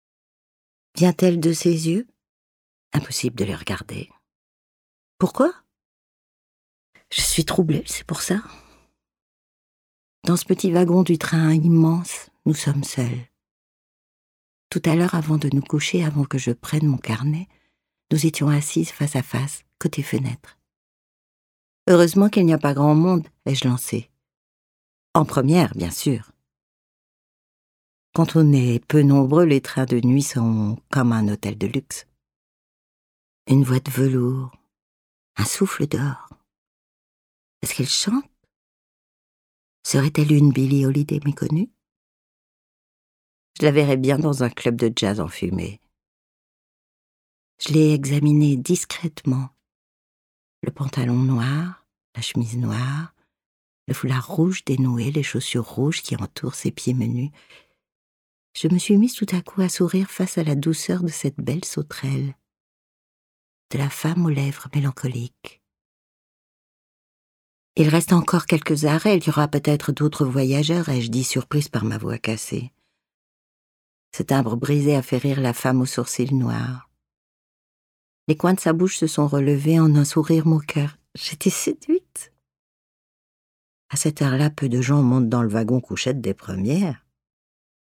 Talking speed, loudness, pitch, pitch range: 135 wpm, -21 LUFS, 140 Hz, 120-160 Hz